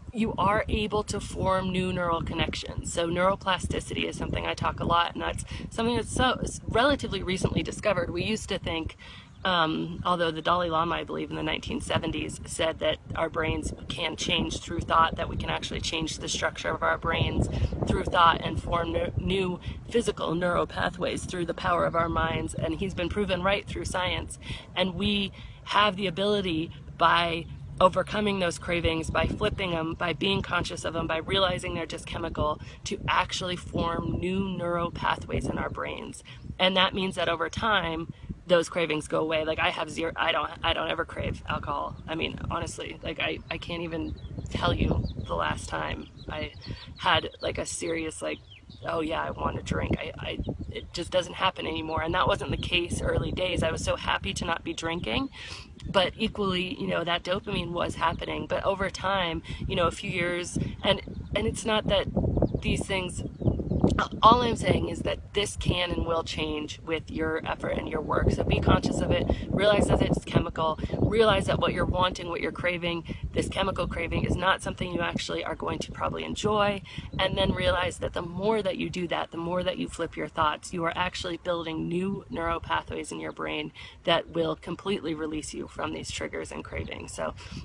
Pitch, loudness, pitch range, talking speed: 170 Hz, -28 LUFS, 160-185 Hz, 195 wpm